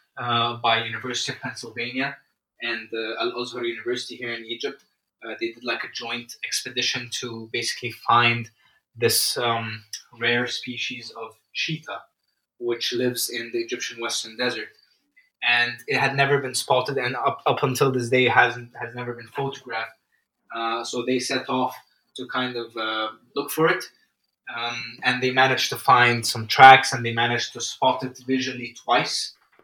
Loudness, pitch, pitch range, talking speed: -23 LUFS, 120 Hz, 115-130 Hz, 160 wpm